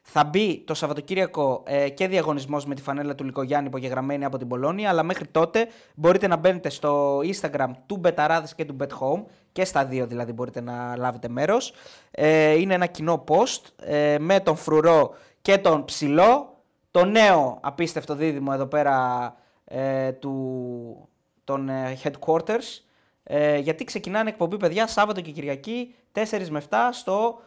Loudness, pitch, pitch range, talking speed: -23 LUFS, 155 Hz, 140-185 Hz, 155 wpm